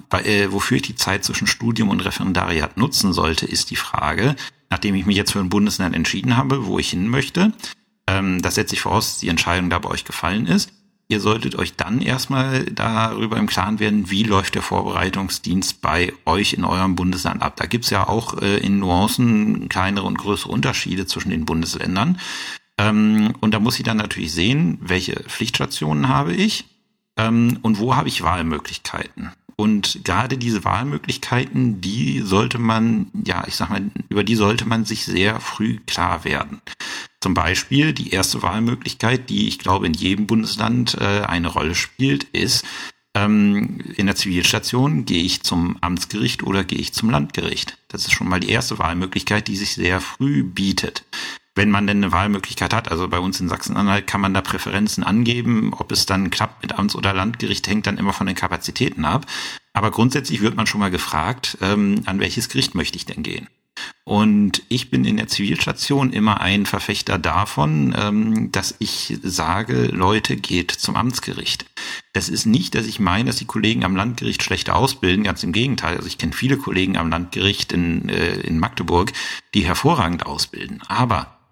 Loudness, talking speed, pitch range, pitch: -20 LUFS, 175 wpm, 95-115 Hz, 105 Hz